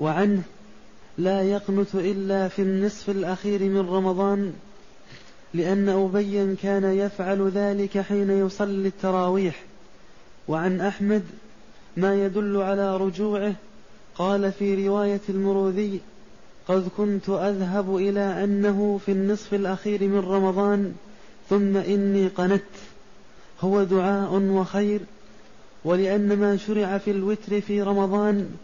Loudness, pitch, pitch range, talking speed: -24 LUFS, 195 Hz, 190-205 Hz, 105 wpm